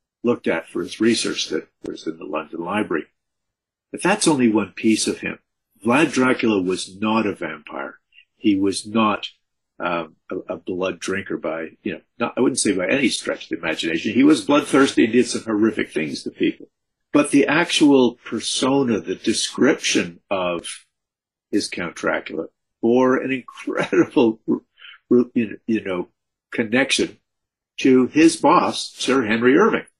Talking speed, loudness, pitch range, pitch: 155 wpm, -20 LUFS, 110-135 Hz, 120 Hz